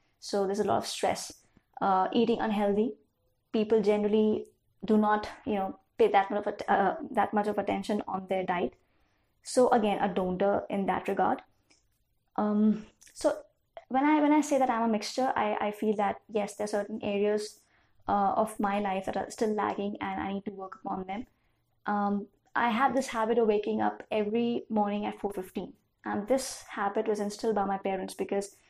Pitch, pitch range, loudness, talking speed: 210 Hz, 200-230 Hz, -29 LUFS, 190 wpm